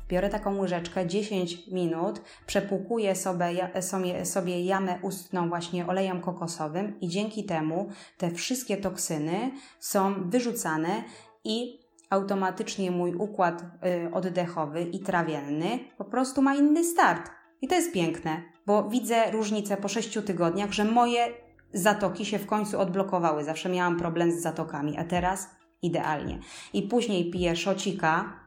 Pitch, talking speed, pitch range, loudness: 190 Hz, 130 wpm, 175-210 Hz, -28 LUFS